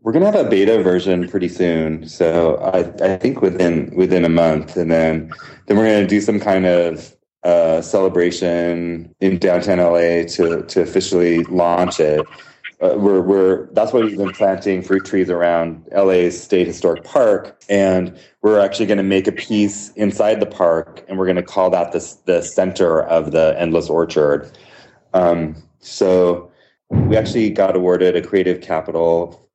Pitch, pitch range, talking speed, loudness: 90 Hz, 85-95 Hz, 175 wpm, -16 LUFS